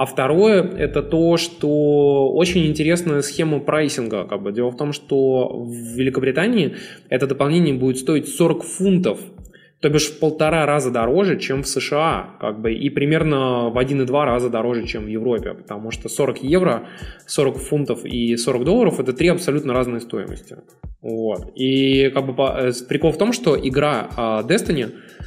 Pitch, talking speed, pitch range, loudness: 140 Hz, 160 wpm, 125-160 Hz, -19 LUFS